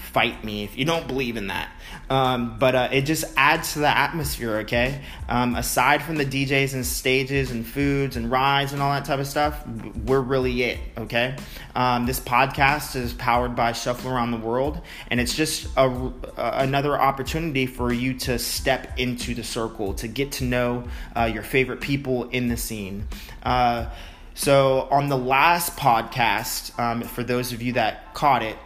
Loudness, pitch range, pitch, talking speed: -23 LUFS, 120-135 Hz, 125 Hz, 185 wpm